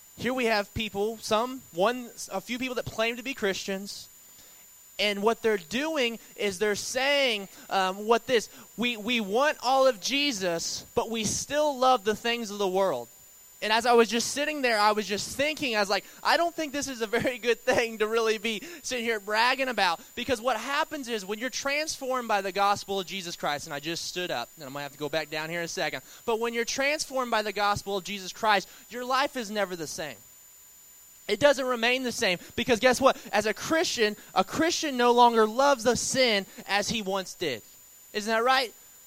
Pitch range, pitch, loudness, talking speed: 205-255 Hz, 230 Hz, -27 LUFS, 215 wpm